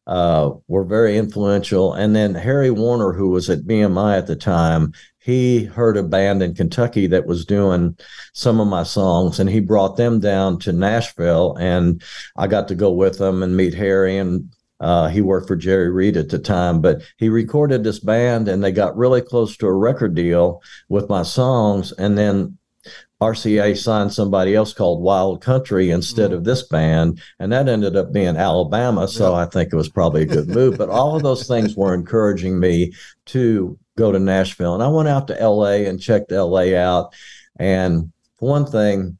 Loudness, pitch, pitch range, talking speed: -17 LUFS, 100 Hz, 90-110 Hz, 190 wpm